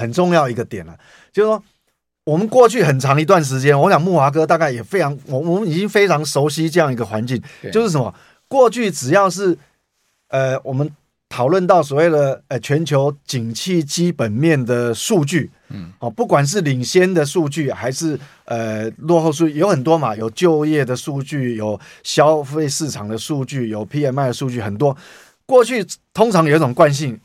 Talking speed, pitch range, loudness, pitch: 275 characters per minute, 125-170 Hz, -17 LUFS, 150 Hz